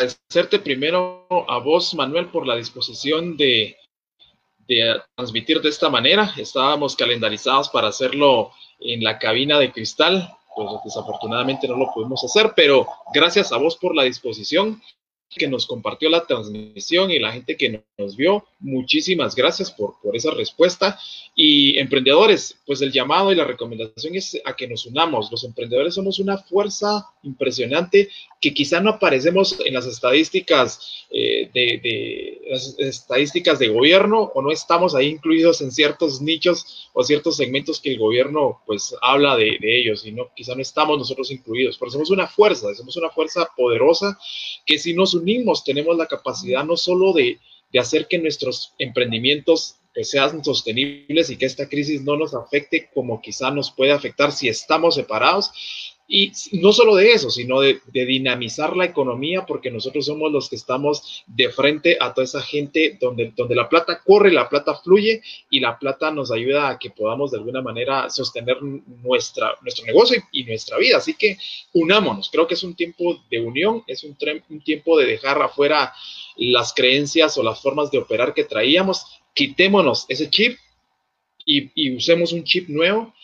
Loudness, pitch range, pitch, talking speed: -19 LUFS, 135-215 Hz, 165 Hz, 175 wpm